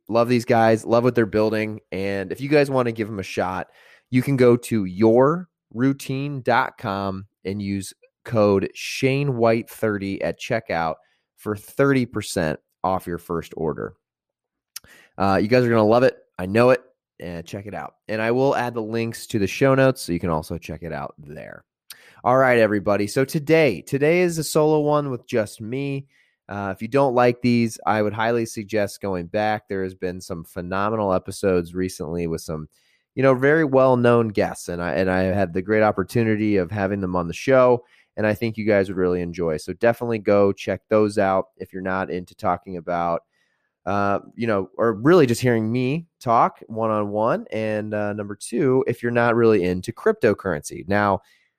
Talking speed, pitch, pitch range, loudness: 195 wpm, 110 Hz, 95-120 Hz, -21 LUFS